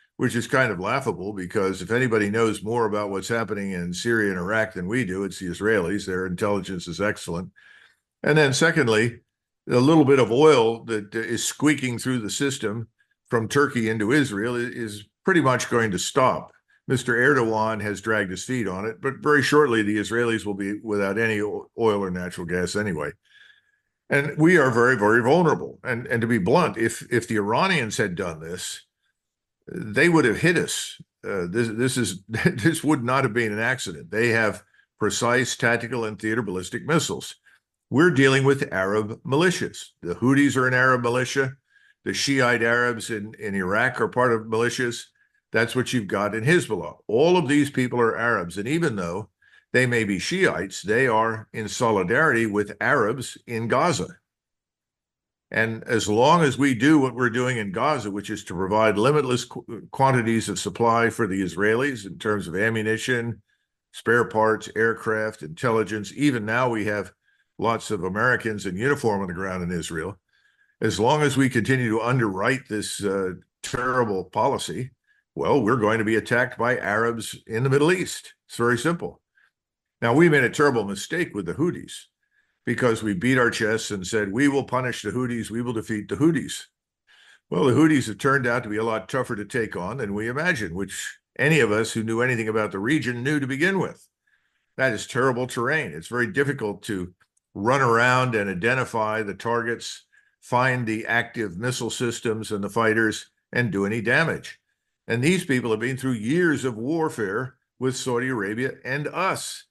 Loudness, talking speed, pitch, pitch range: -23 LUFS, 180 wpm, 115 Hz, 105-130 Hz